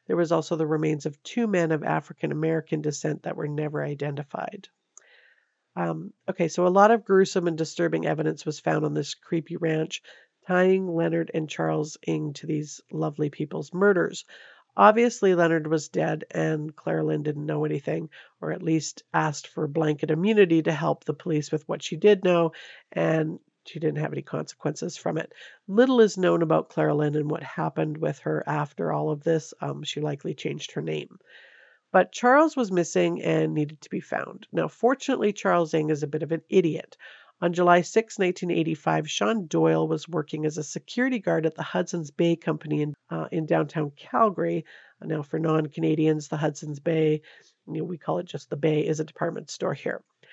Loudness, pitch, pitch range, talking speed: -26 LUFS, 160 Hz, 150-175 Hz, 185 wpm